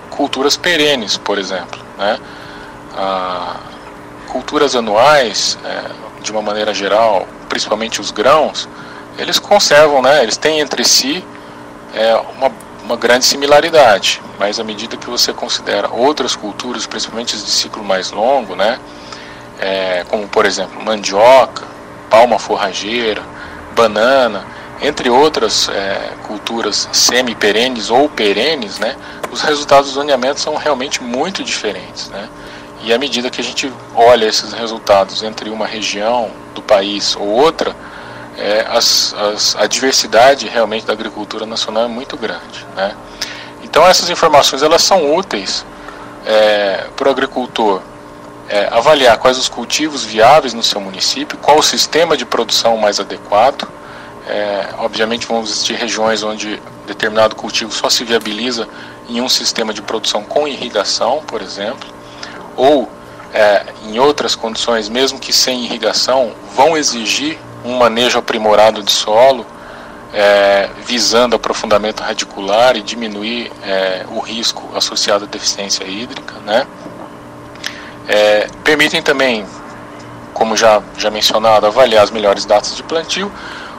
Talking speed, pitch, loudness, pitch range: 135 wpm, 110 Hz, -13 LUFS, 105-125 Hz